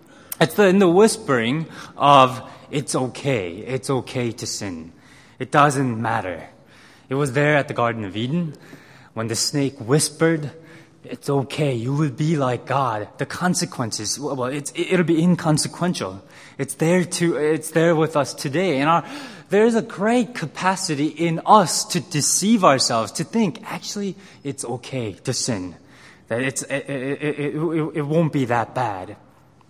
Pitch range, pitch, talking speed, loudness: 130-170 Hz, 145 Hz, 155 wpm, -21 LUFS